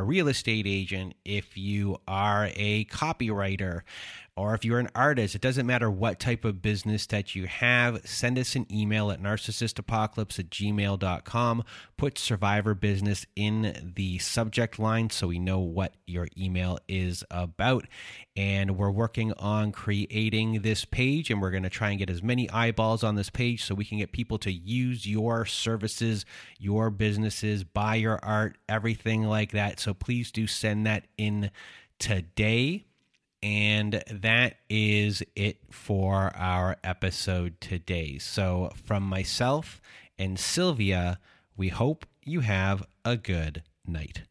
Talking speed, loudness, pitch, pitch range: 150 wpm, -28 LUFS, 105 Hz, 95-115 Hz